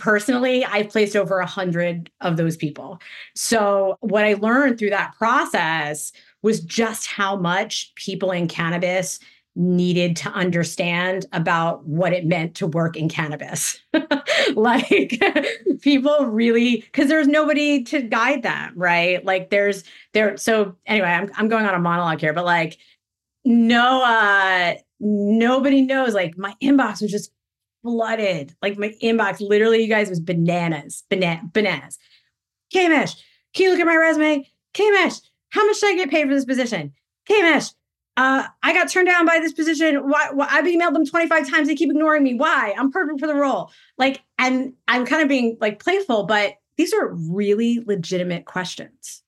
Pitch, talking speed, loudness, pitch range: 220 Hz, 165 wpm, -19 LUFS, 185-285 Hz